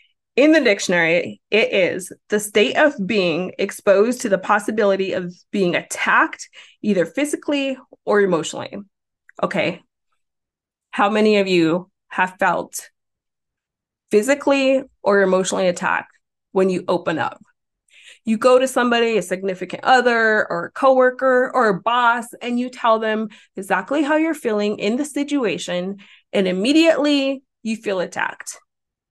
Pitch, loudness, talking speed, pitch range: 220 Hz, -19 LUFS, 130 wpm, 190-265 Hz